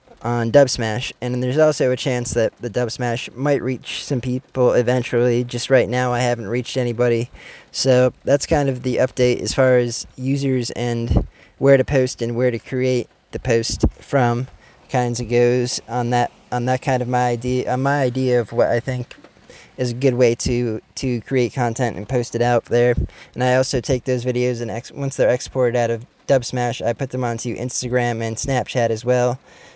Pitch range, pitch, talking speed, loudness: 120-130 Hz, 125 Hz, 200 wpm, -20 LUFS